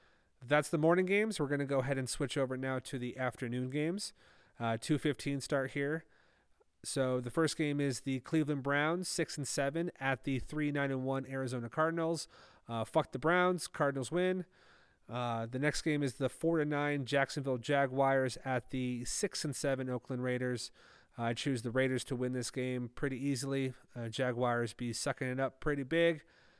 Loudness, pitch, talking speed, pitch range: -35 LUFS, 135 Hz, 180 wpm, 125-150 Hz